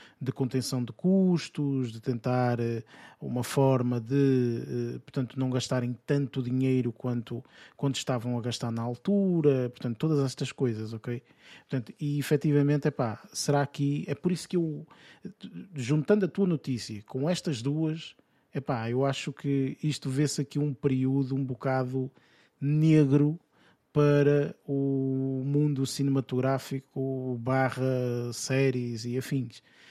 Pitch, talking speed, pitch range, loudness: 135 Hz, 130 wpm, 125-145 Hz, -29 LUFS